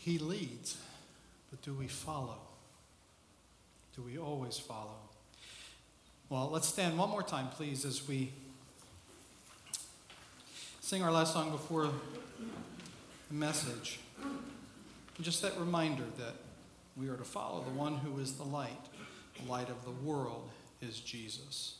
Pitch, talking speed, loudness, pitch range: 140 Hz, 130 wpm, -39 LUFS, 125-160 Hz